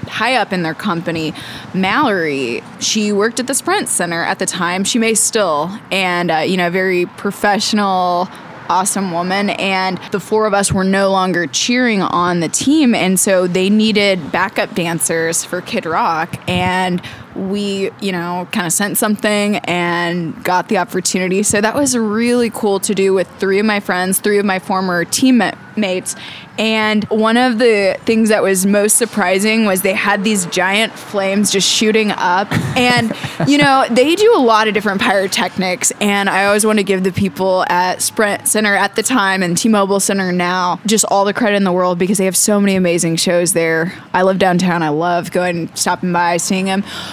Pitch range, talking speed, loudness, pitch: 180-215 Hz, 190 wpm, -14 LUFS, 195 Hz